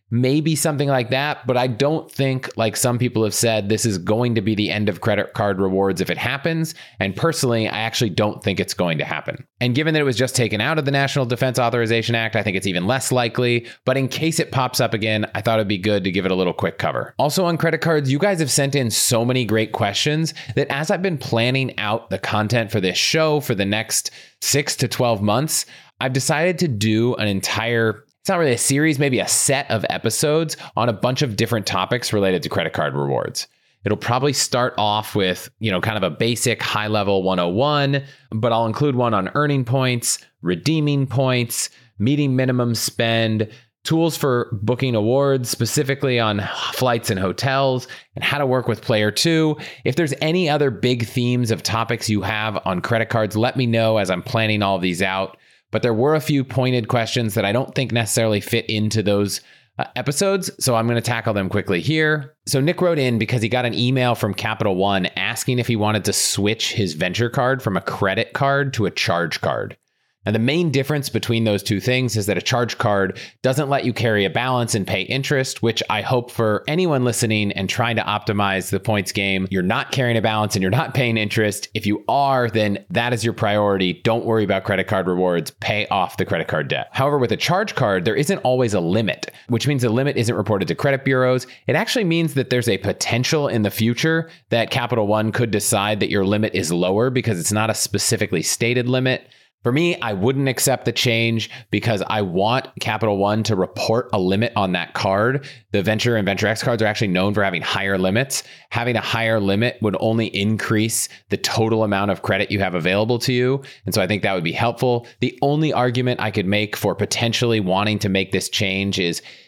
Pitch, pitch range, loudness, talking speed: 115 Hz, 105-130 Hz, -20 LUFS, 220 wpm